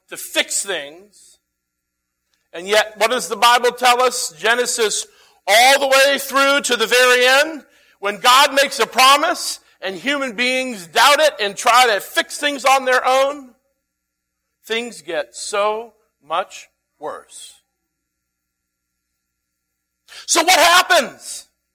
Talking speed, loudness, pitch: 125 wpm, -15 LUFS, 240 Hz